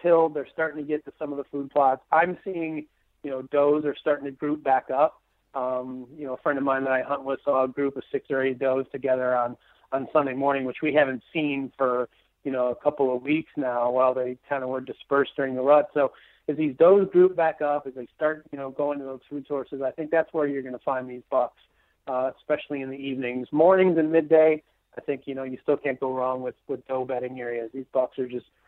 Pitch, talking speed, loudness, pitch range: 140 Hz, 250 wpm, -25 LUFS, 130-150 Hz